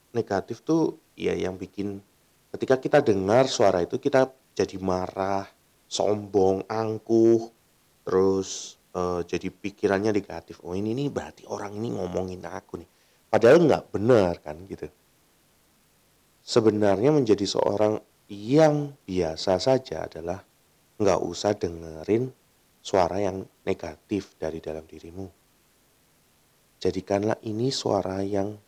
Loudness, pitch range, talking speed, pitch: -25 LUFS, 90-110 Hz, 115 wpm, 100 Hz